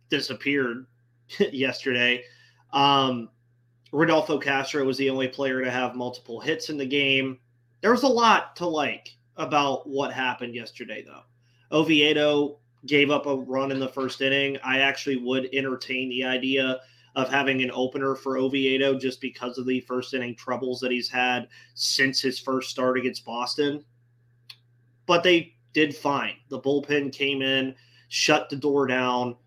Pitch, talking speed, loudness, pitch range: 130 Hz, 155 wpm, -24 LUFS, 125-140 Hz